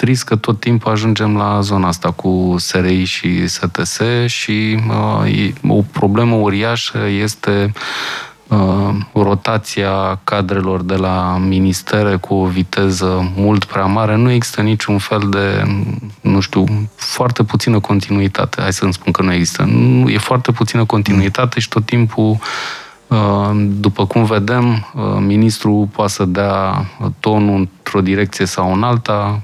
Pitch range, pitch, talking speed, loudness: 95-110 Hz, 105 Hz, 140 wpm, -15 LUFS